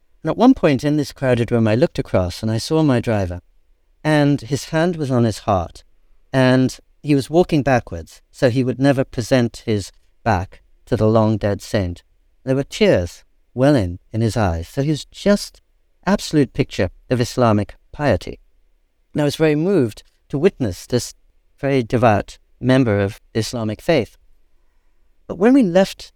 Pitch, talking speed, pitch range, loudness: 120 Hz, 165 wpm, 100-140 Hz, -18 LUFS